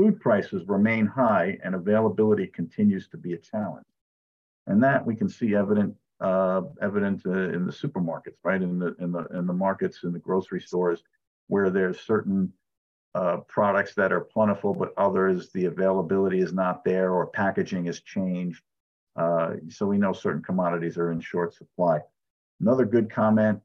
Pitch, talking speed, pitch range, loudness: 95 Hz, 170 wpm, 90-105 Hz, -26 LUFS